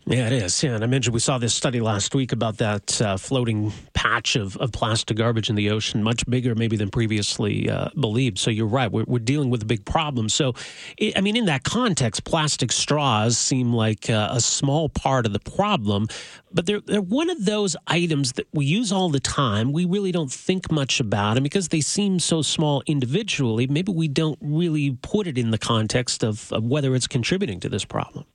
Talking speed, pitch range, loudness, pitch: 220 wpm, 115-155 Hz, -22 LUFS, 130 Hz